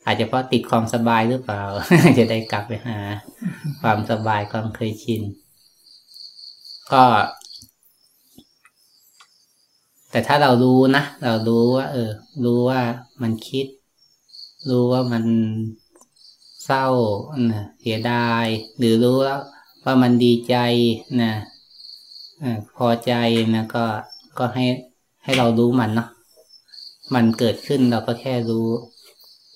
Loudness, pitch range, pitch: -20 LUFS, 115-125 Hz, 120 Hz